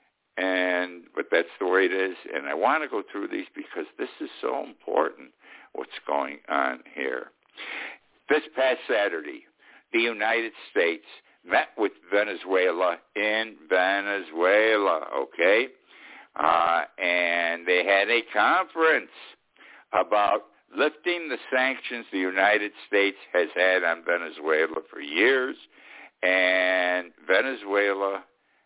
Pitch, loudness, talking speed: 105 Hz, -25 LUFS, 115 wpm